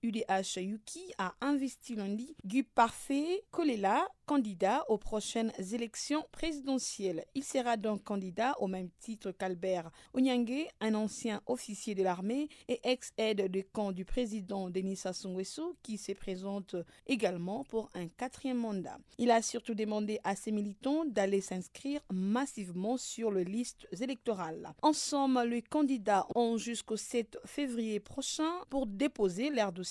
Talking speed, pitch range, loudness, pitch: 140 wpm, 195-260 Hz, -35 LUFS, 225 Hz